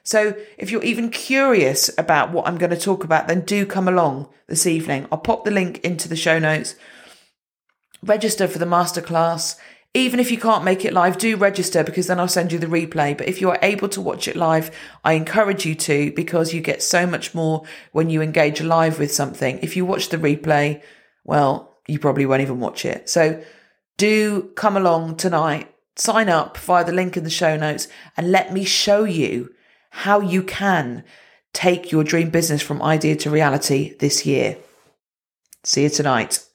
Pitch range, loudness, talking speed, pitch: 155-190 Hz, -19 LUFS, 195 wpm, 170 Hz